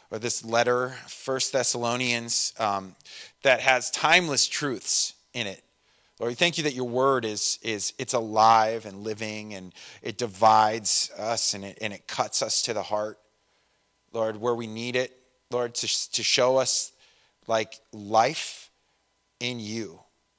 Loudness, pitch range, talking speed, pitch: -25 LUFS, 110-125 Hz, 155 wpm, 115 Hz